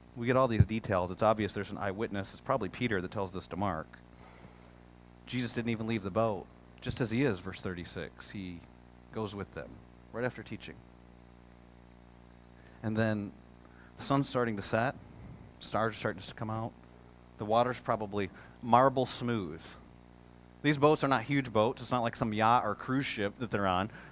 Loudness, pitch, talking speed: -32 LUFS, 100 Hz, 180 wpm